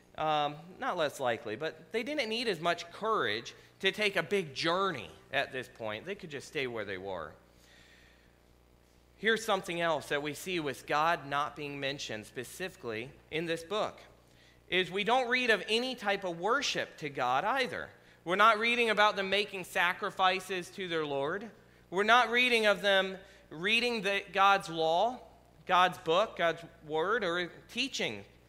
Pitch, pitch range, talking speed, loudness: 180 Hz, 145-200 Hz, 165 wpm, -31 LUFS